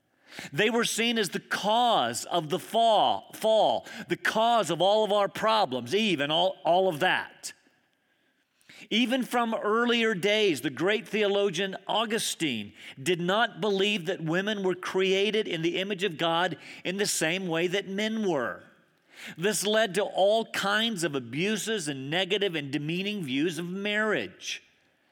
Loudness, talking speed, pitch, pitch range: -27 LUFS, 155 wpm, 200 Hz, 180-220 Hz